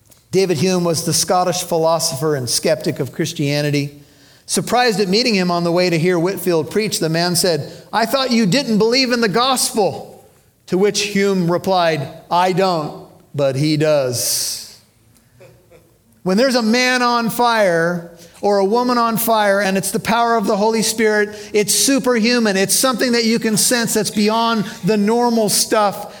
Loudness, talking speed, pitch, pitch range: -16 LUFS, 165 wpm, 195 Hz, 165-225 Hz